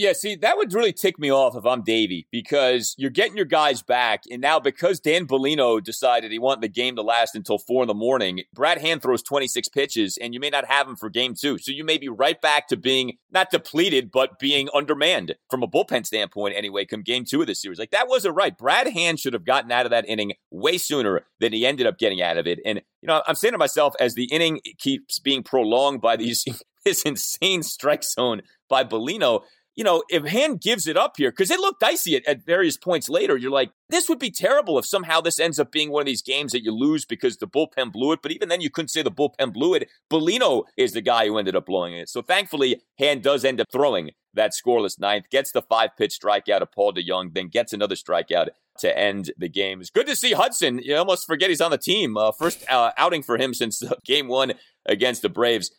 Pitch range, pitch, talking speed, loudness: 120-185 Hz, 140 Hz, 245 wpm, -22 LUFS